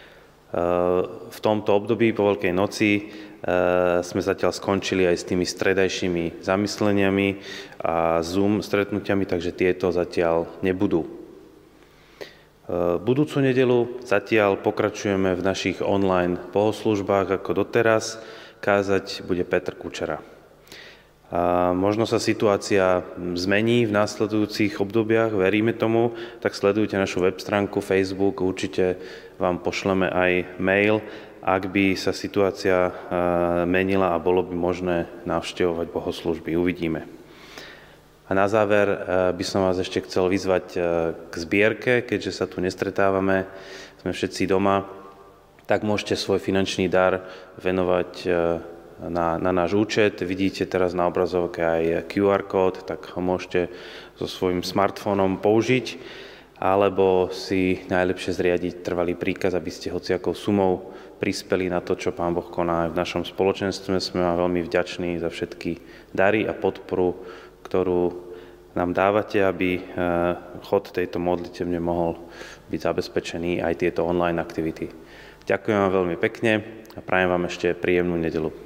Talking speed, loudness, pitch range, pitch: 125 wpm, -23 LUFS, 90-100 Hz, 95 Hz